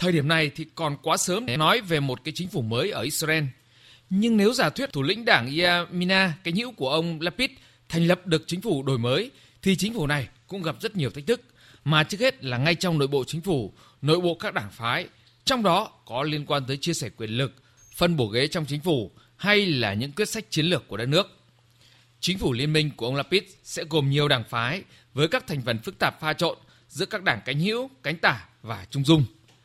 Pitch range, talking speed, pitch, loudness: 130-175 Hz, 240 wpm, 155 Hz, -25 LUFS